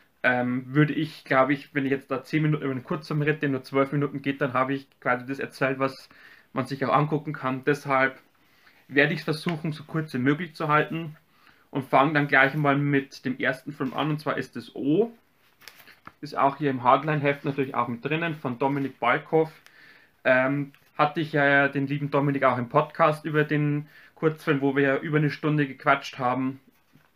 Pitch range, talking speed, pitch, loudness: 135-150 Hz, 200 wpm, 140 Hz, -25 LUFS